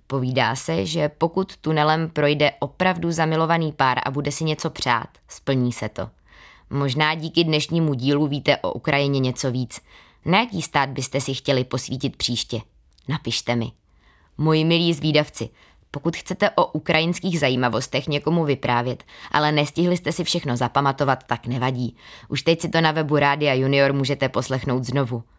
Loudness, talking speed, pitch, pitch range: -22 LUFS, 155 wpm, 140 Hz, 125-160 Hz